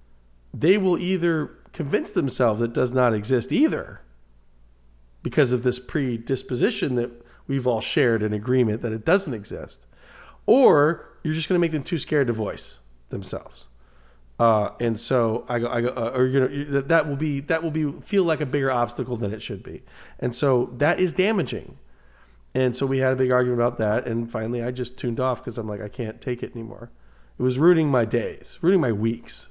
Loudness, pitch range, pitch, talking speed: -23 LUFS, 110-140 Hz, 125 Hz, 200 wpm